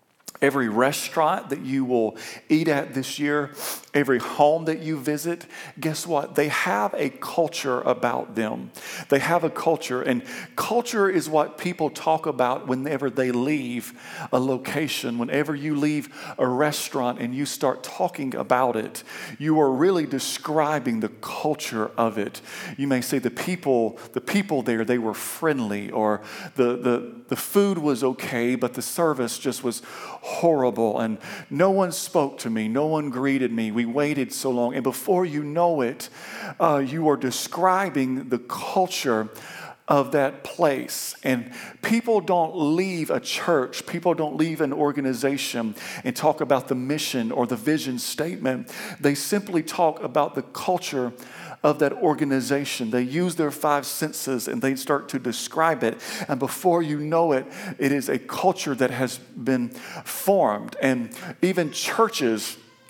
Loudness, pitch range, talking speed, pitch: -24 LUFS, 125-160 Hz, 155 wpm, 140 Hz